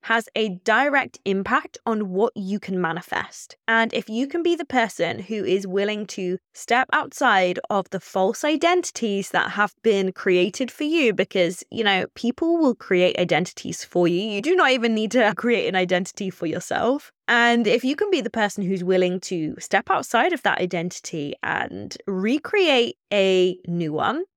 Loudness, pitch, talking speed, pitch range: -22 LUFS, 210 Hz, 175 wpm, 185-250 Hz